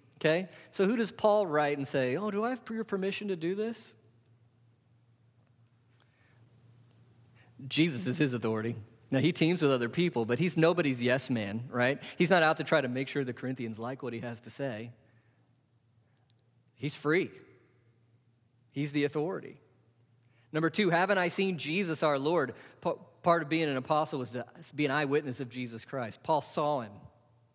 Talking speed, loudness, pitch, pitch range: 170 wpm, -31 LUFS, 130 Hz, 120-160 Hz